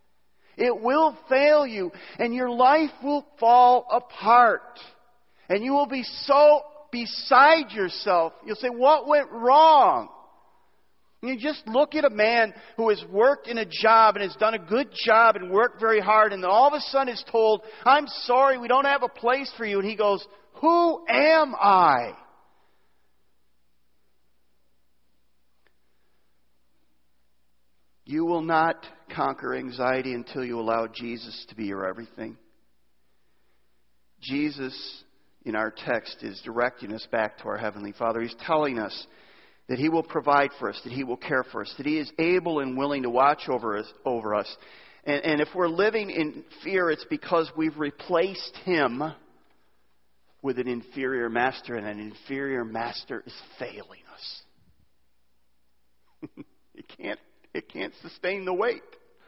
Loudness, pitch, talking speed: -23 LUFS, 170 Hz, 150 wpm